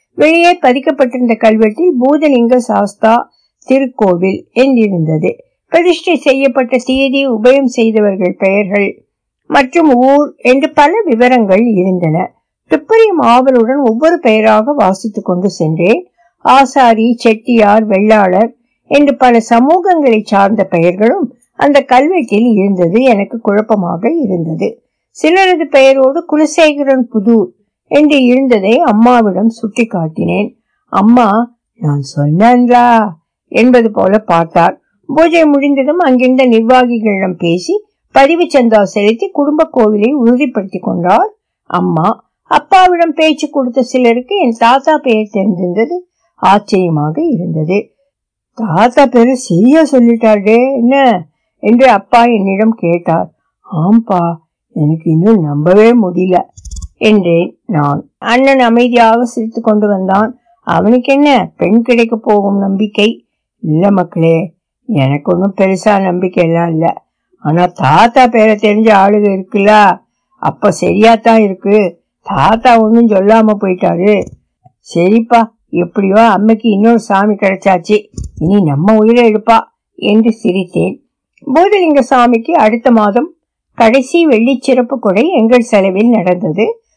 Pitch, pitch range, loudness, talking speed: 225 Hz, 200-260 Hz, -9 LUFS, 100 wpm